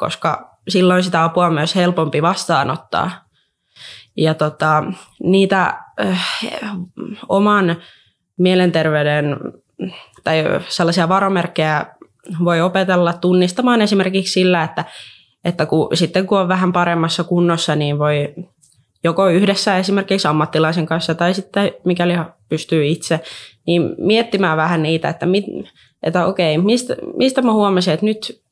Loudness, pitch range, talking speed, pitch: -16 LUFS, 160-195 Hz, 120 wpm, 175 Hz